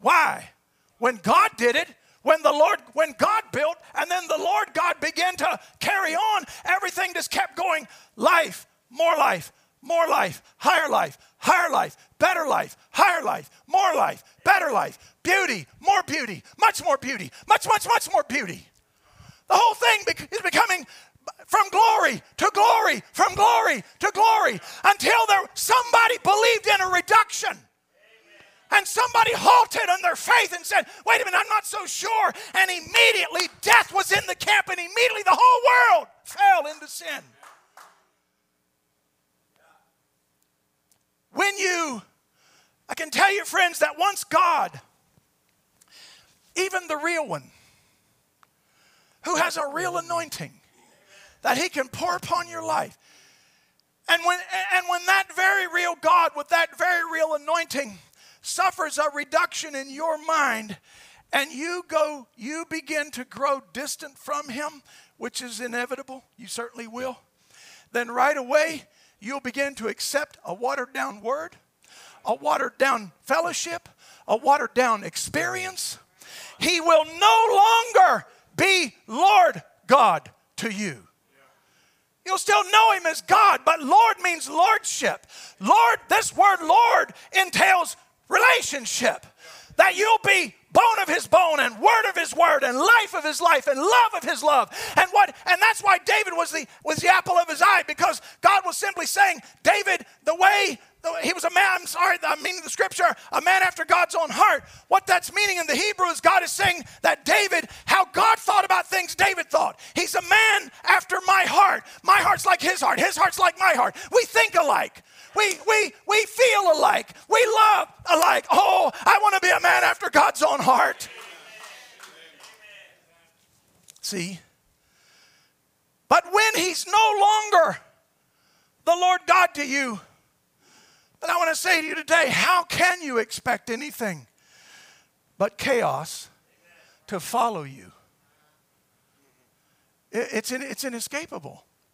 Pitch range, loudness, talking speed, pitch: 300-395 Hz, -21 LUFS, 150 wpm, 350 Hz